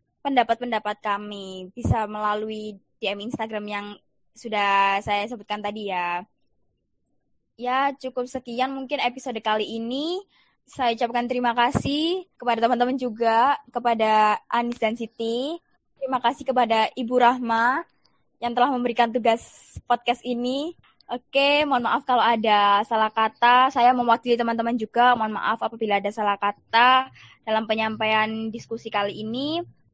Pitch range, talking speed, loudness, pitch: 215-250 Hz, 125 wpm, -23 LUFS, 235 Hz